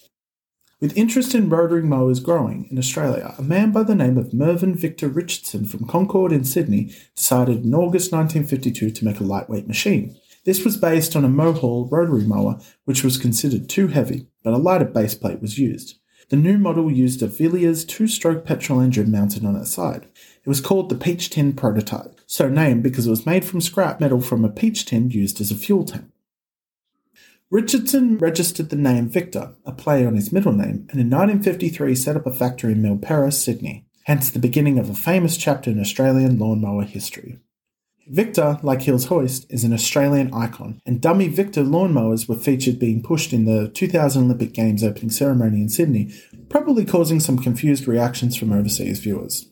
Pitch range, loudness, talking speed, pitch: 115-170 Hz, -19 LUFS, 185 wpm, 135 Hz